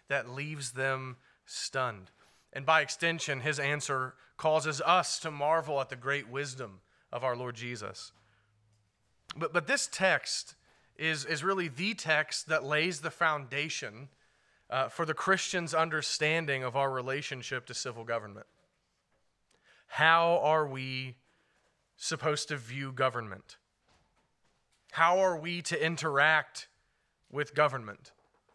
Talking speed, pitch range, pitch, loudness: 125 wpm, 130-160 Hz, 140 Hz, -31 LUFS